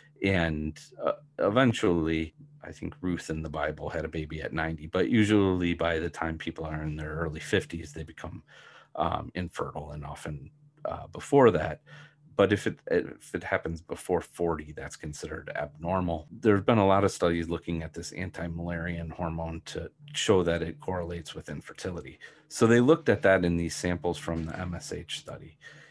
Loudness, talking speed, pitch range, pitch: -29 LUFS, 175 wpm, 80-95 Hz, 85 Hz